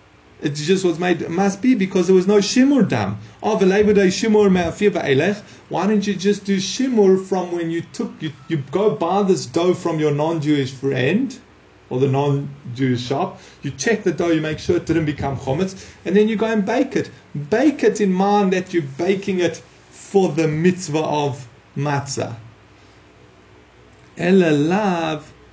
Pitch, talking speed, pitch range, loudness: 175 Hz, 170 wpm, 145-200 Hz, -19 LUFS